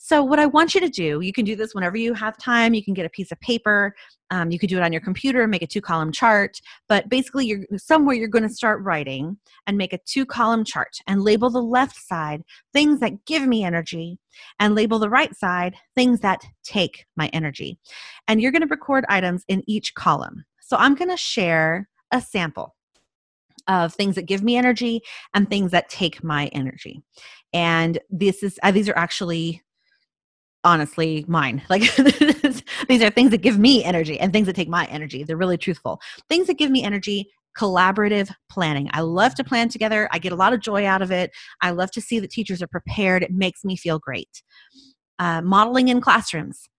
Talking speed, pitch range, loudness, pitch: 210 wpm, 175-245 Hz, -20 LUFS, 200 Hz